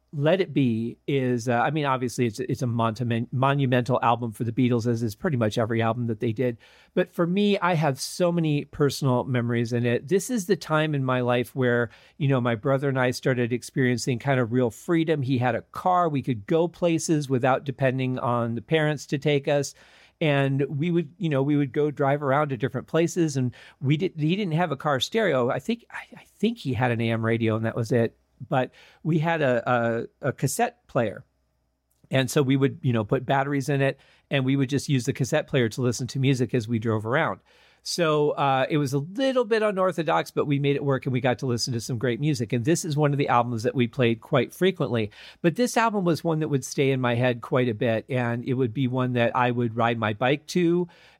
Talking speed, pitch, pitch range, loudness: 240 wpm, 135 Hz, 120-155 Hz, -25 LUFS